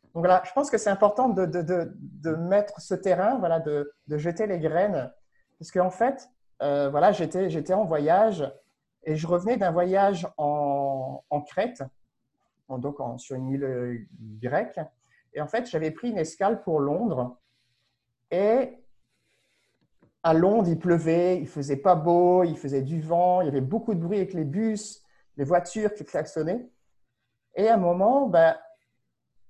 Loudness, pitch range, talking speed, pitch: -25 LUFS, 145-195 Hz, 175 wpm, 165 Hz